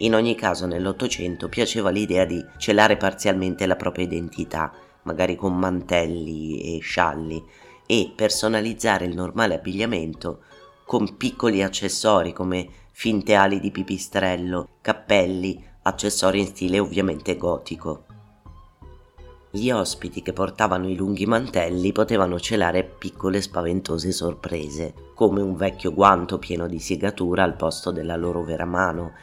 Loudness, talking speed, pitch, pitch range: -23 LUFS, 125 wpm, 95 Hz, 85-100 Hz